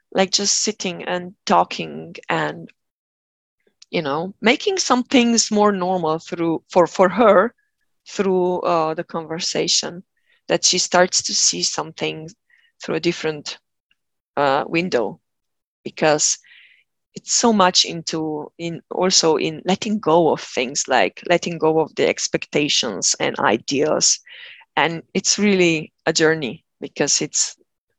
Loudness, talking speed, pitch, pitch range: -19 LUFS, 125 wpm, 180 Hz, 160-215 Hz